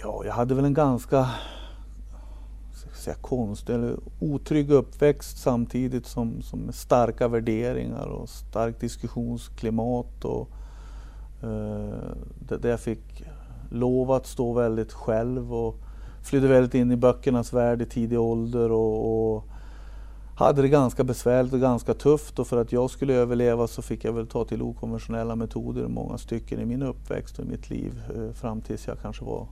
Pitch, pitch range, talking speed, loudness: 120 Hz, 115-125 Hz, 155 wpm, -26 LUFS